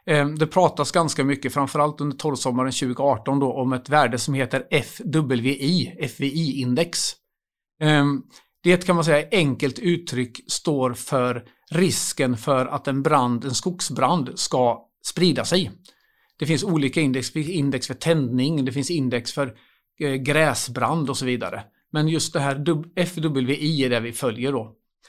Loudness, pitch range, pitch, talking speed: -22 LUFS, 130-155 Hz, 140 Hz, 140 wpm